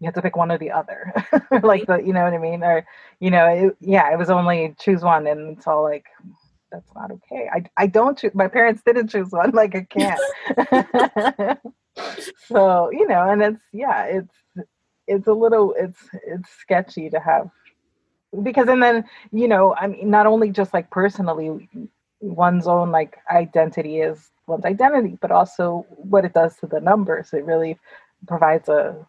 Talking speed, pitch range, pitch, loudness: 185 wpm, 165-215 Hz, 190 Hz, -19 LUFS